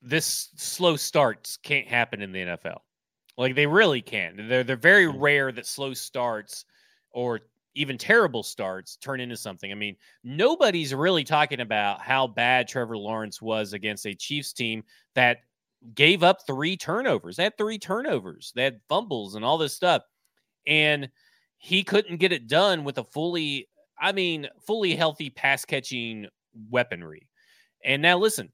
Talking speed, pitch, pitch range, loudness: 160 wpm, 135 Hz, 115-165 Hz, -24 LUFS